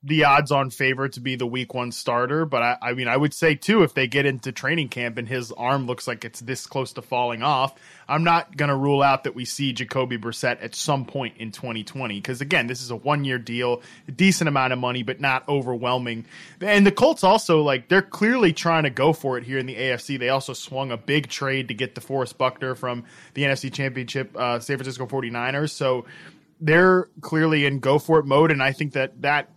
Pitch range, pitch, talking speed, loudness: 125-150 Hz, 135 Hz, 225 wpm, -22 LUFS